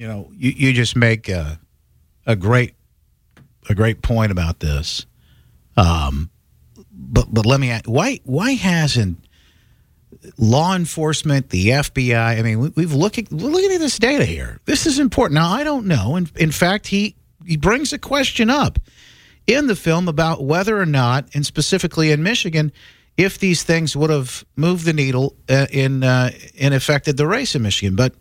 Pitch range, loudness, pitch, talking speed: 115-175 Hz, -18 LUFS, 145 Hz, 180 wpm